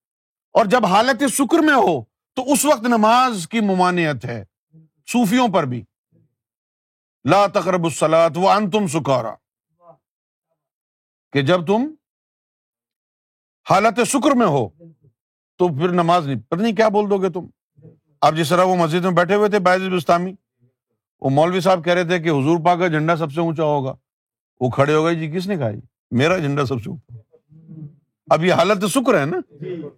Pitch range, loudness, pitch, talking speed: 145-200 Hz, -18 LUFS, 170 Hz, 165 wpm